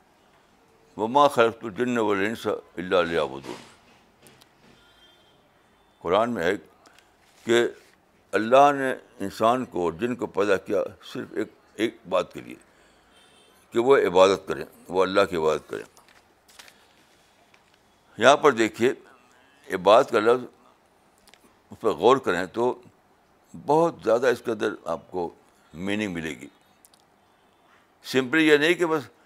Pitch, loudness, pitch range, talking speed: 125 Hz, -23 LUFS, 110-160 Hz, 125 wpm